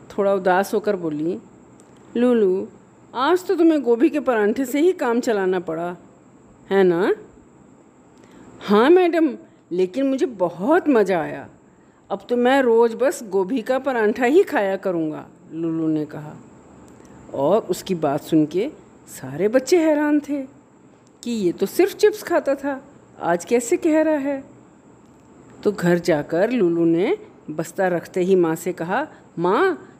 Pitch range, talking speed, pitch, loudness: 185-300 Hz, 145 wpm, 235 Hz, -20 LUFS